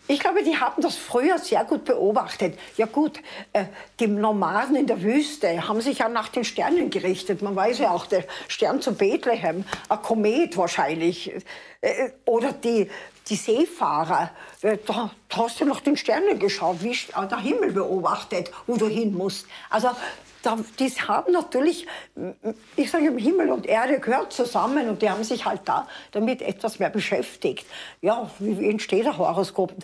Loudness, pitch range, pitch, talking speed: -24 LUFS, 210-290 Hz, 230 Hz, 160 wpm